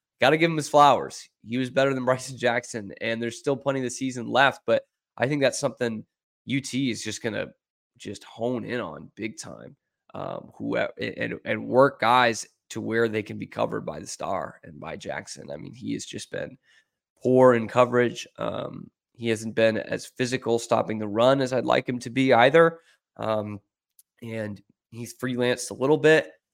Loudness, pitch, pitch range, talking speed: -24 LUFS, 120 Hz, 110-130 Hz, 190 wpm